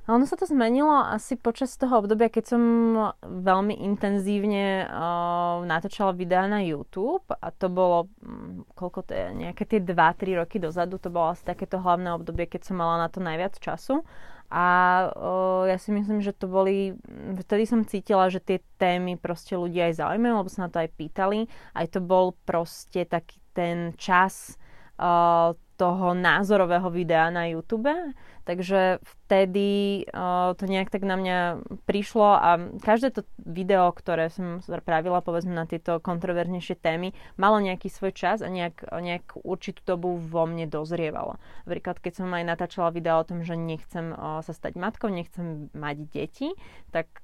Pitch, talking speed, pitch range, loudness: 185 Hz, 165 wpm, 170-205 Hz, -26 LUFS